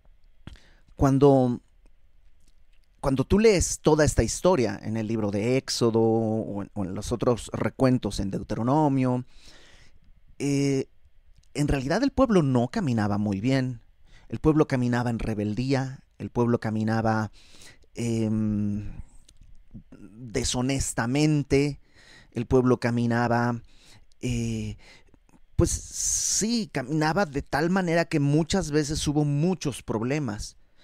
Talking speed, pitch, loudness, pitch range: 110 wpm, 120 Hz, -25 LUFS, 105-140 Hz